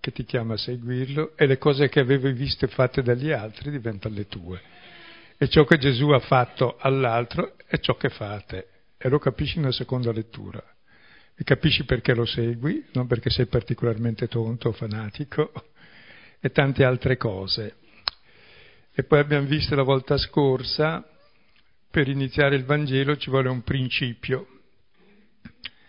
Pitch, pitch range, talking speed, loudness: 130 Hz, 120-145 Hz, 150 wpm, -24 LUFS